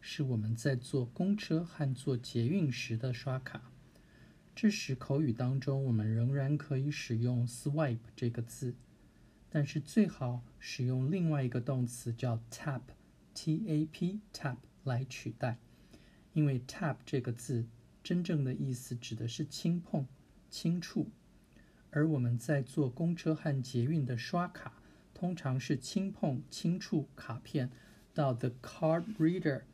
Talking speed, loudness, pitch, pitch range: 240 characters per minute, -35 LUFS, 135 Hz, 125-160 Hz